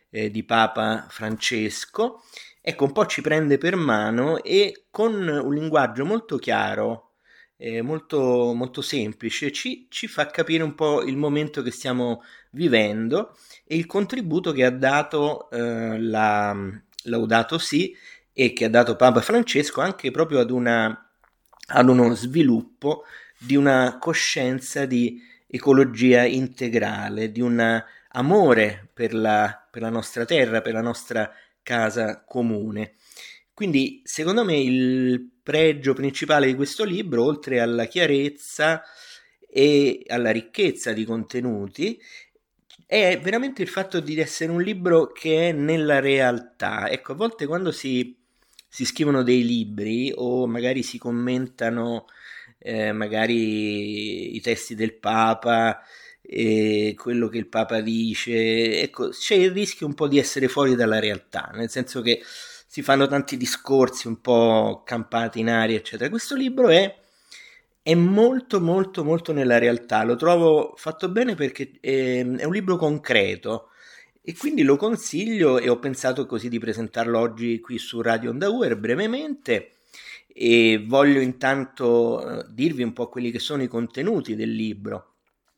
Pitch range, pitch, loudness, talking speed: 115-160 Hz, 130 Hz, -22 LUFS, 140 wpm